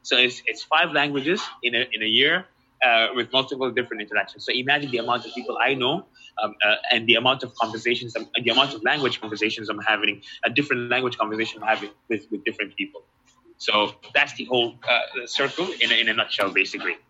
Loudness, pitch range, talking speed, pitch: -22 LUFS, 110-130 Hz, 210 wpm, 120 Hz